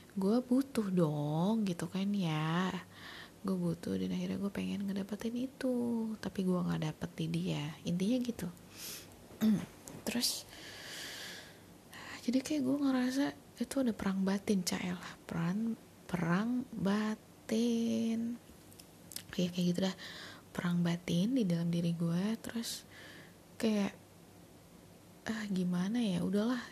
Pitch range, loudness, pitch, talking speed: 175-230 Hz, -35 LUFS, 195 Hz, 115 wpm